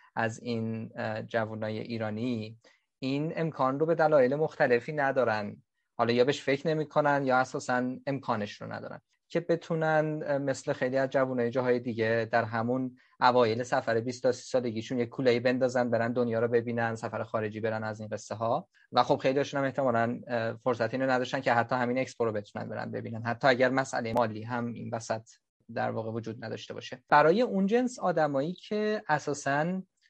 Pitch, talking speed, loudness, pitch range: 125 Hz, 170 wpm, -29 LUFS, 115-140 Hz